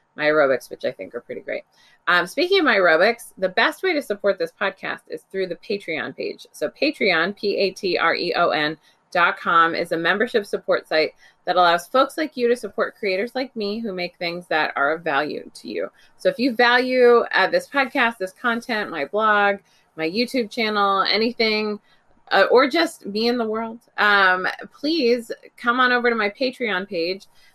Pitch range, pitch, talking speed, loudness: 185-250 Hz, 215 Hz, 200 wpm, -20 LUFS